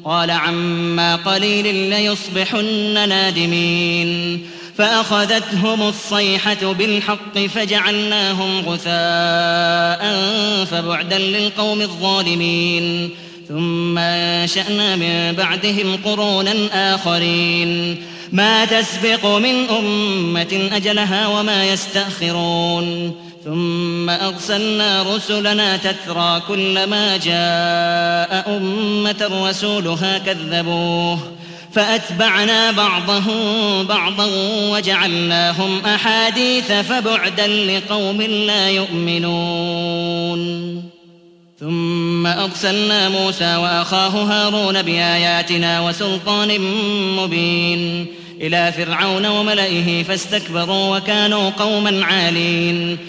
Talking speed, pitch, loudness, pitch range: 65 wpm, 190 Hz, -16 LUFS, 170-210 Hz